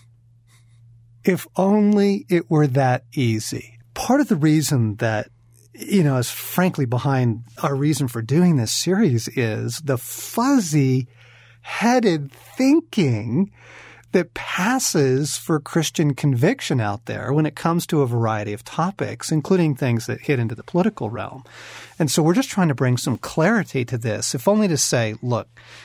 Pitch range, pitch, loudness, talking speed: 115-170 Hz, 135 Hz, -20 LUFS, 155 wpm